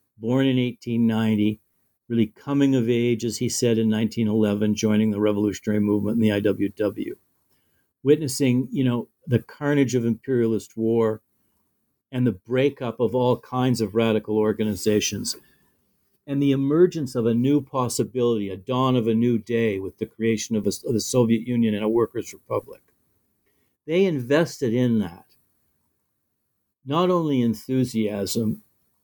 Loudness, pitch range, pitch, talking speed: -23 LUFS, 110-130 Hz, 115 Hz, 145 wpm